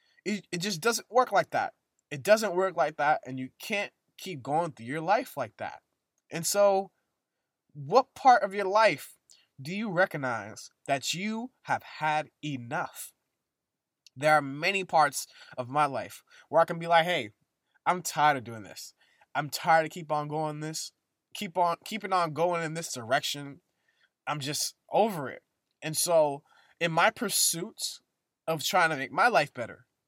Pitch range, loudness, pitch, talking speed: 150-195 Hz, -28 LUFS, 165 Hz, 170 wpm